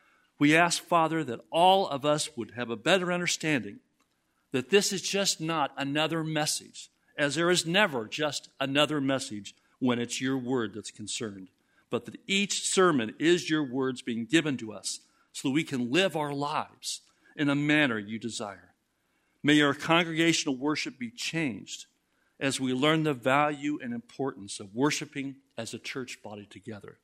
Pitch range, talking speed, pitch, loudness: 130-165 Hz, 165 wpm, 150 Hz, -28 LUFS